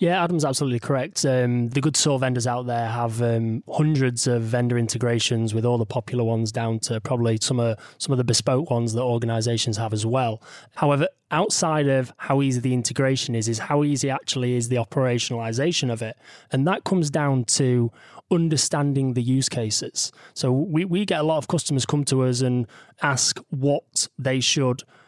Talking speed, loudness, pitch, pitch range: 190 wpm, -23 LUFS, 130 Hz, 120-145 Hz